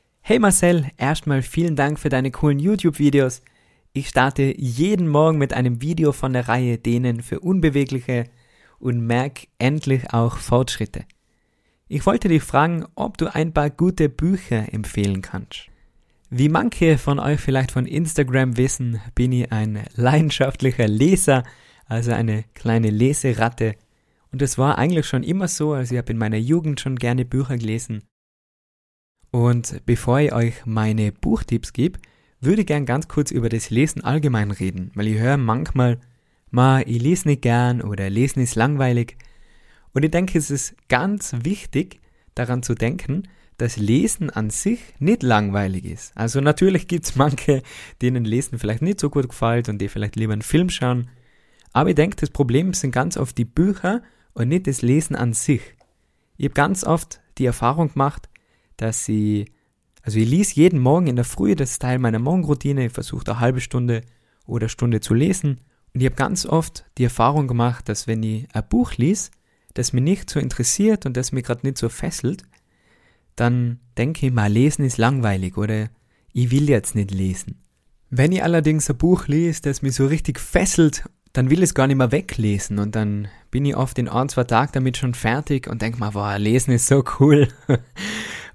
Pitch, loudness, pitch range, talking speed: 130 Hz, -20 LUFS, 115-150 Hz, 180 wpm